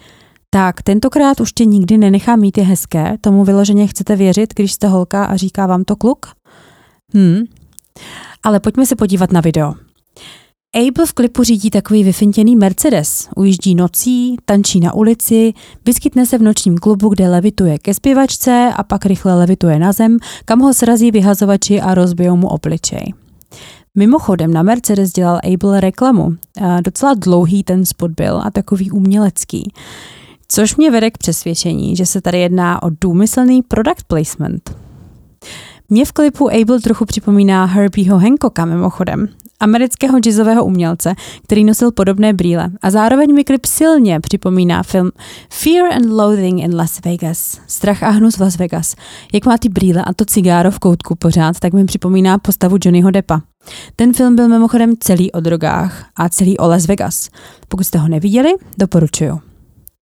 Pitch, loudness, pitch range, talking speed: 200 Hz, -12 LUFS, 180-225 Hz, 160 wpm